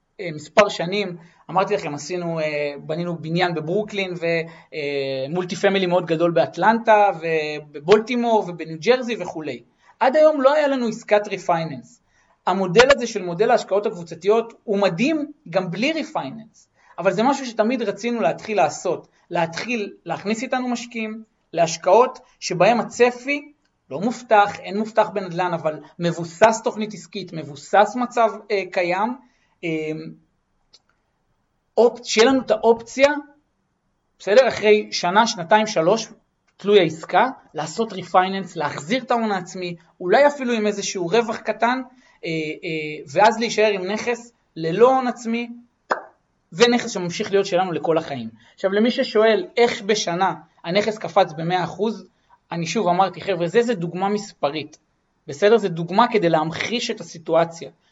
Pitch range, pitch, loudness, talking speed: 170-230 Hz, 205 Hz, -21 LUFS, 125 wpm